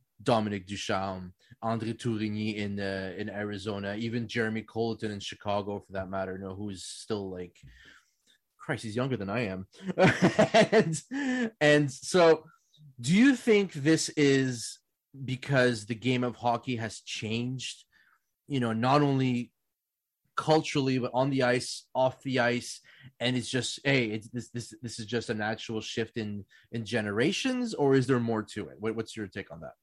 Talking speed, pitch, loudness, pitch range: 165 wpm, 120 Hz, -29 LUFS, 110-135 Hz